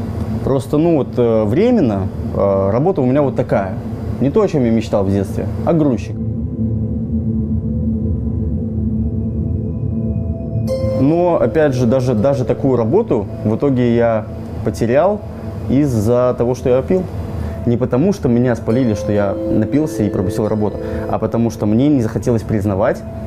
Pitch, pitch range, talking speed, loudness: 110 Hz, 110-125 Hz, 135 wpm, -16 LUFS